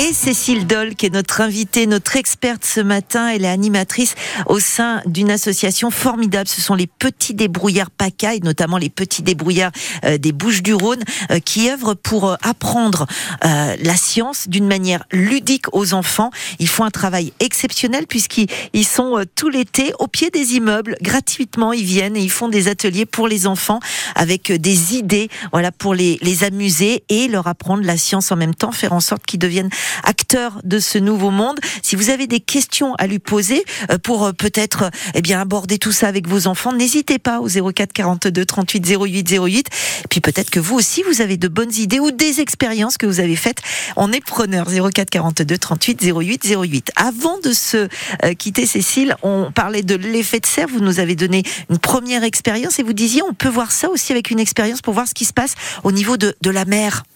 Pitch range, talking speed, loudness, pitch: 190-235 Hz, 205 wpm, -16 LUFS, 210 Hz